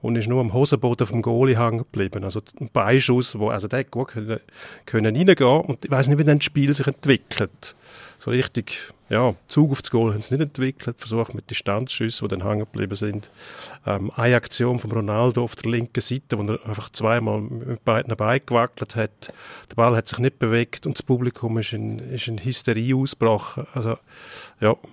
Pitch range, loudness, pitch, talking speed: 110-130 Hz, -22 LUFS, 120 Hz, 195 wpm